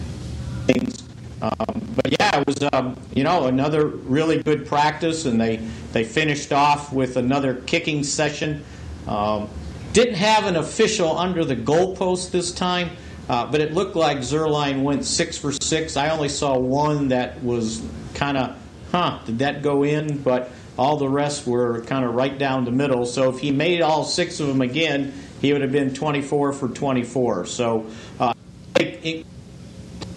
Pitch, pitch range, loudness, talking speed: 140 Hz, 125-155 Hz, -22 LUFS, 170 wpm